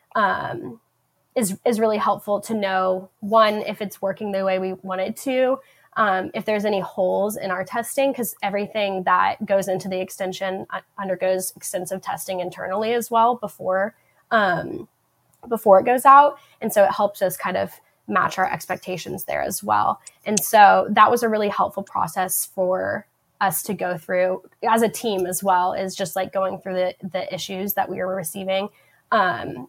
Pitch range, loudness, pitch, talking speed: 185-215 Hz, -21 LUFS, 195 Hz, 180 wpm